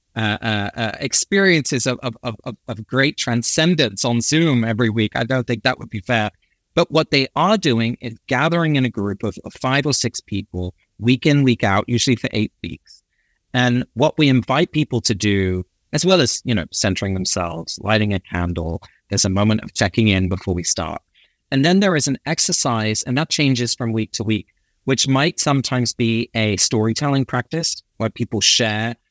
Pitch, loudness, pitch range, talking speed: 120 Hz, -19 LUFS, 105-135 Hz, 195 wpm